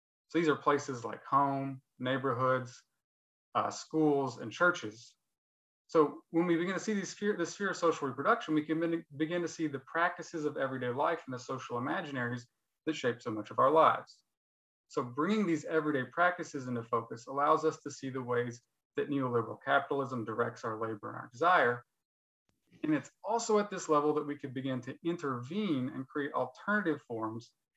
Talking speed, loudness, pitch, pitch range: 175 wpm, -33 LUFS, 145 Hz, 125-165 Hz